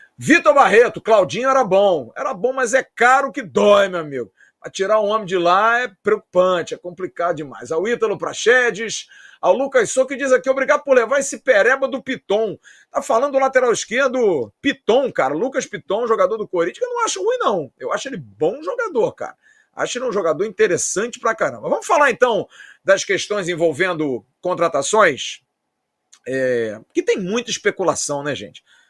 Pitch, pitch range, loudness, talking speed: 235 Hz, 185-275 Hz, -18 LUFS, 175 wpm